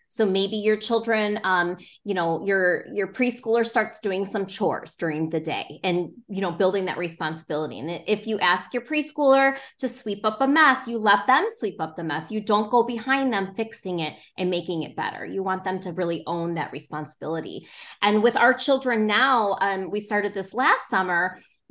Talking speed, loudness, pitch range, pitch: 195 wpm, -24 LUFS, 175-230 Hz, 200 Hz